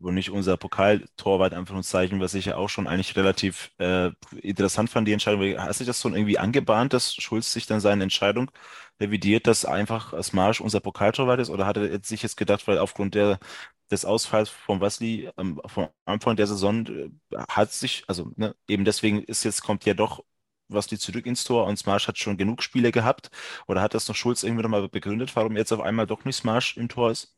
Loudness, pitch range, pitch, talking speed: -25 LUFS, 100-115 Hz, 105 Hz, 215 wpm